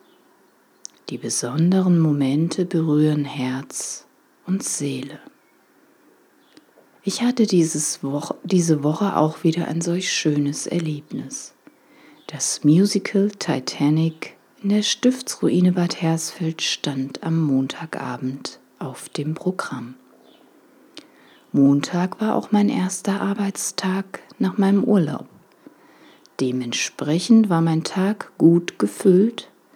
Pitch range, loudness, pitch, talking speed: 150-200 Hz, -21 LUFS, 165 Hz, 95 wpm